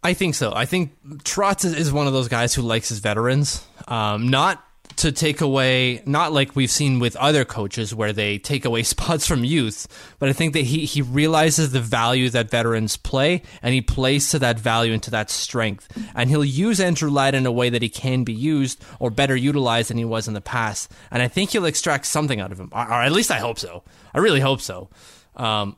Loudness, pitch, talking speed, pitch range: -20 LUFS, 130 Hz, 230 wpm, 115-145 Hz